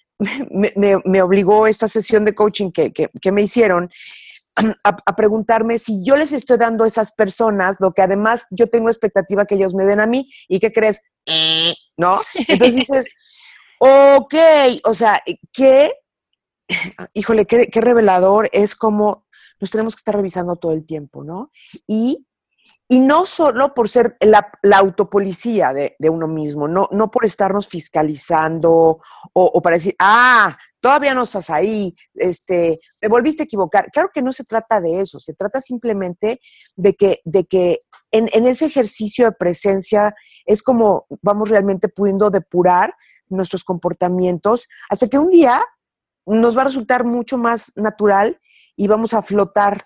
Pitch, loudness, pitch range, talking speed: 210 Hz, -15 LUFS, 190-240 Hz, 165 wpm